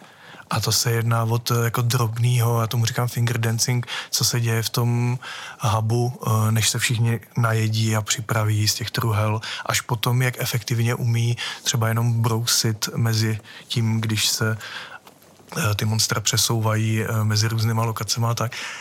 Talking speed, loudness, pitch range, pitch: 150 wpm, -22 LUFS, 110-120 Hz, 115 Hz